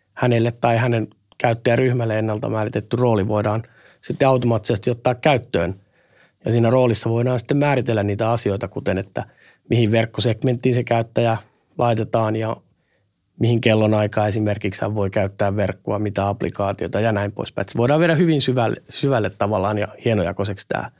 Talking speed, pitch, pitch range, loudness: 145 wpm, 115 Hz, 105-125 Hz, -20 LUFS